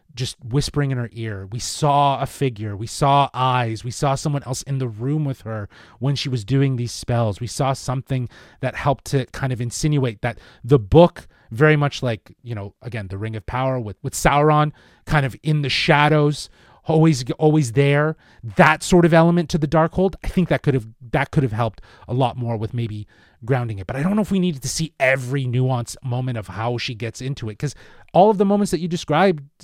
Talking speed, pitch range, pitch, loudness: 225 wpm, 120-150 Hz, 130 Hz, -20 LUFS